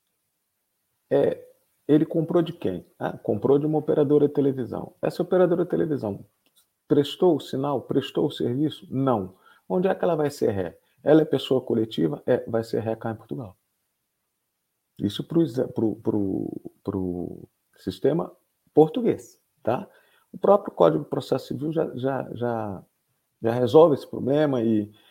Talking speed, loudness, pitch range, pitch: 155 wpm, -24 LUFS, 115-160 Hz, 140 Hz